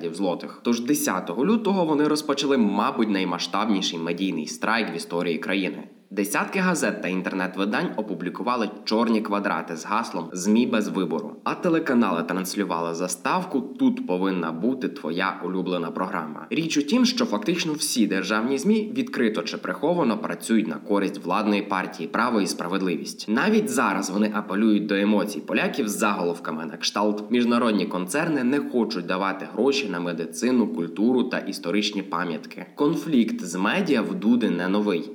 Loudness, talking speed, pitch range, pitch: -24 LUFS, 145 wpm, 95-150 Hz, 105 Hz